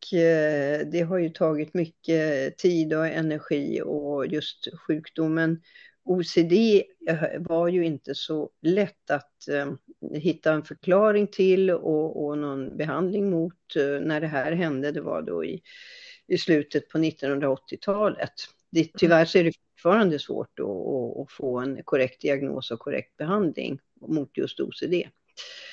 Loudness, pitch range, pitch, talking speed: -26 LUFS, 150-175 Hz, 160 Hz, 125 wpm